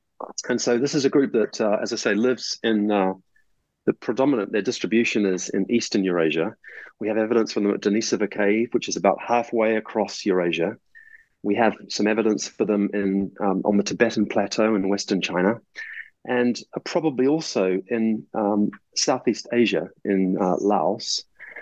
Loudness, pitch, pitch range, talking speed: -23 LUFS, 110 Hz, 100-120 Hz, 170 wpm